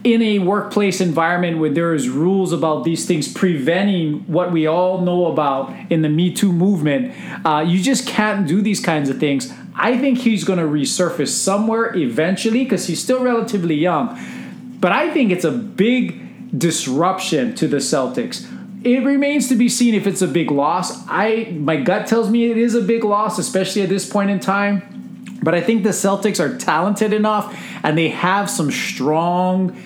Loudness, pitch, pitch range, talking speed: -17 LUFS, 190 Hz, 165-220 Hz, 185 wpm